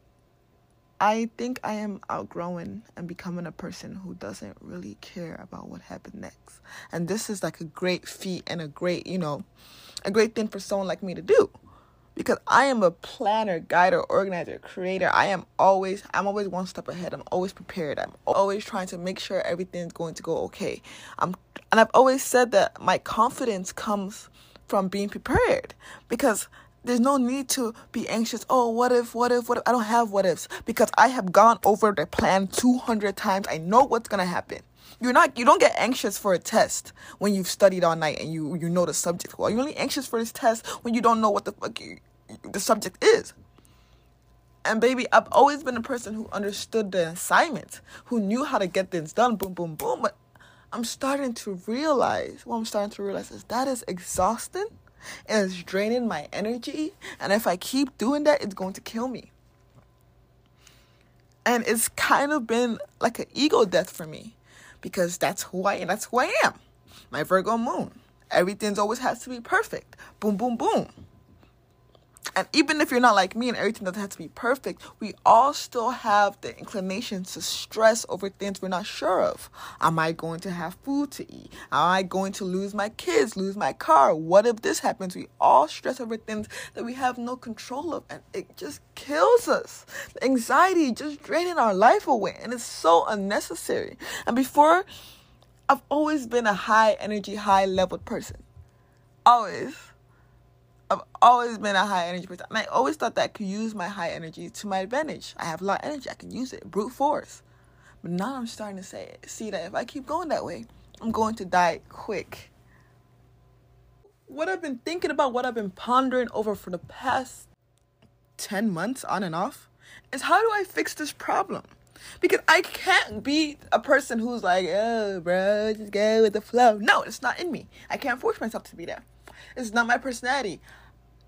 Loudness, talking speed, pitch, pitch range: -25 LUFS, 200 wpm, 220 Hz, 190-255 Hz